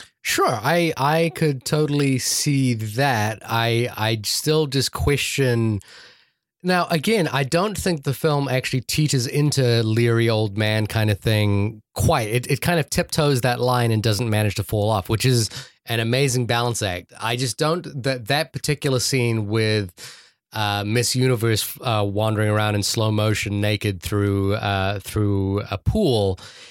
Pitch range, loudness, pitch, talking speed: 105-140 Hz, -21 LUFS, 120 Hz, 160 wpm